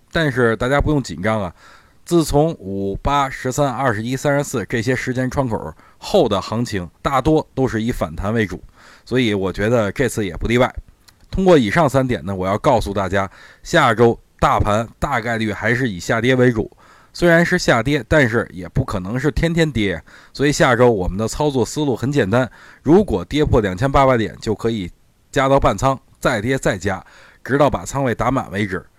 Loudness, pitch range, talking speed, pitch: -18 LUFS, 105-140 Hz, 280 characters per minute, 120 Hz